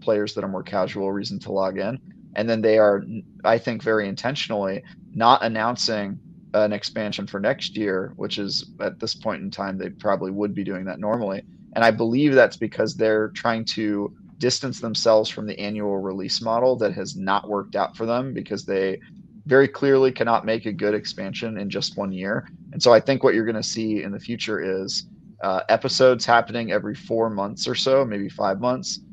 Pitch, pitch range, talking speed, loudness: 110 Hz, 100-120 Hz, 200 wpm, -23 LUFS